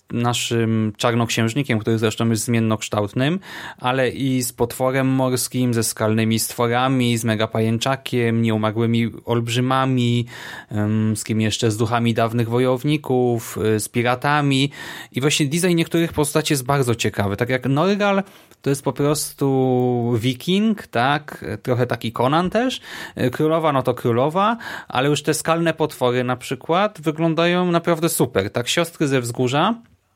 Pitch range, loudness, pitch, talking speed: 115-150 Hz, -20 LUFS, 125 Hz, 135 wpm